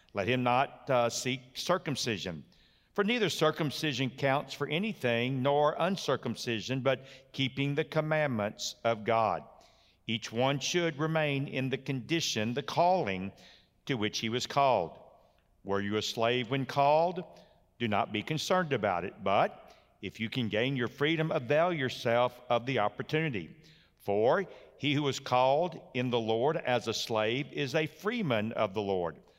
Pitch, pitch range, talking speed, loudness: 130 Hz, 115-155 Hz, 155 wpm, -31 LUFS